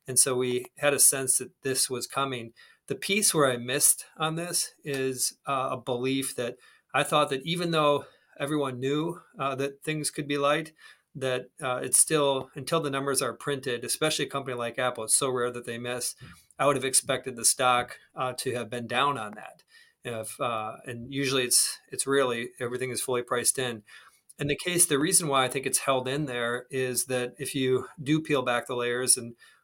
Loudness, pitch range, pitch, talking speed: -27 LUFS, 125-145 Hz, 135 Hz, 205 wpm